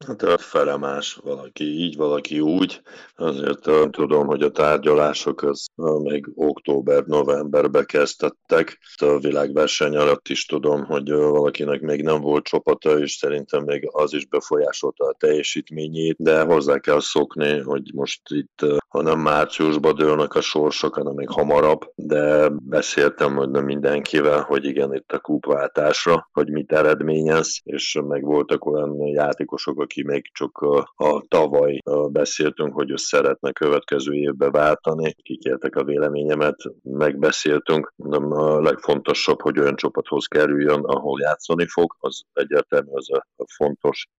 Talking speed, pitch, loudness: 135 wpm, 75 Hz, -20 LUFS